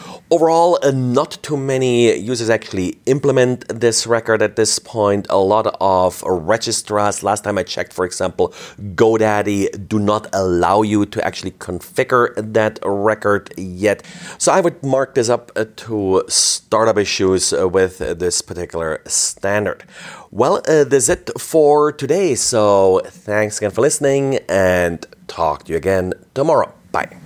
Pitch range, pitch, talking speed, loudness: 95-130 Hz, 105 Hz, 145 wpm, -16 LUFS